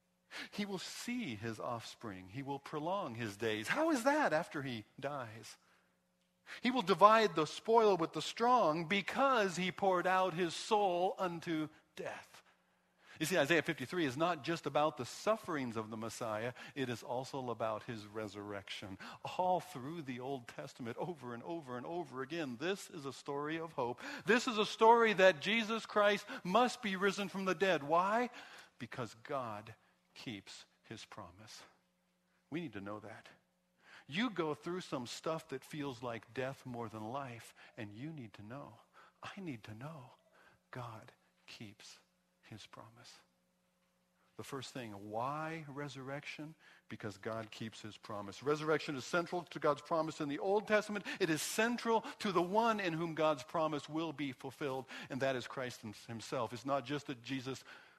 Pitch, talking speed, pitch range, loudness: 150 Hz, 165 wpm, 125-185 Hz, -37 LUFS